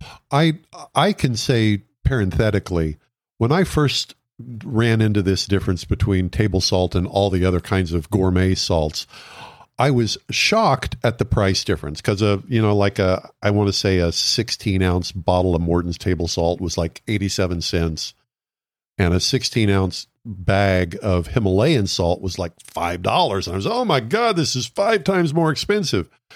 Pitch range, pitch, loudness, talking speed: 90-120 Hz, 100 Hz, -20 LUFS, 170 wpm